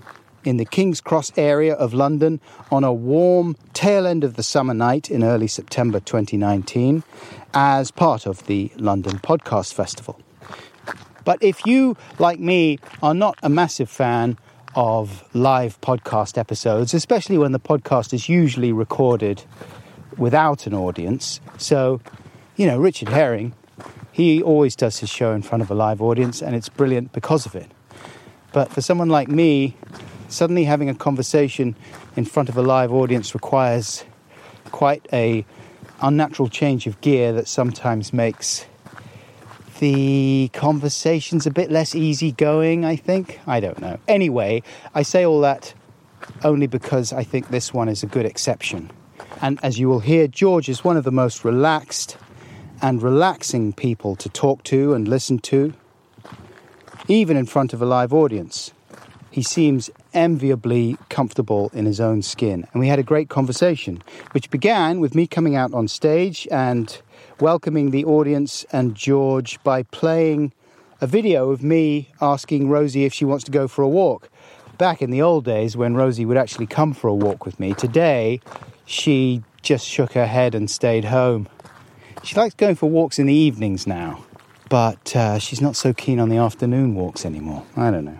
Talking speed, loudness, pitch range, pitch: 165 wpm, -19 LUFS, 115-150 Hz, 130 Hz